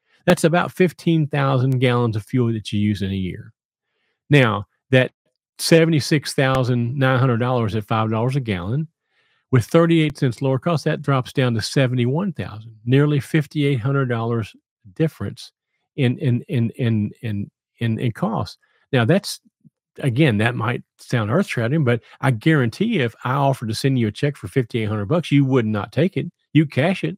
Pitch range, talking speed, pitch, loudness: 115-150 Hz, 155 wpm, 130 Hz, -20 LUFS